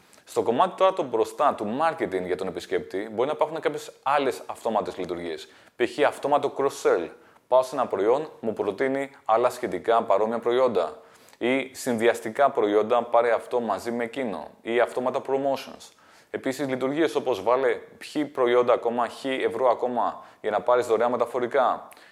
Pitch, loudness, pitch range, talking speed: 130 Hz, -25 LUFS, 120-145 Hz, 150 wpm